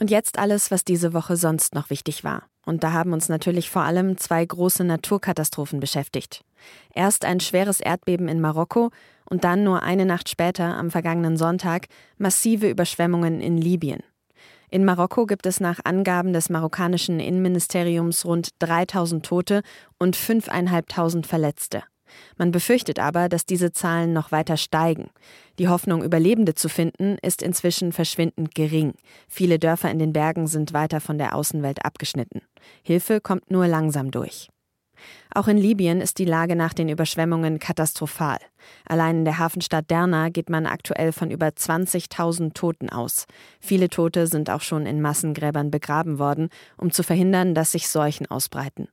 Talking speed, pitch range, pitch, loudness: 155 wpm, 160-180 Hz, 170 Hz, -22 LUFS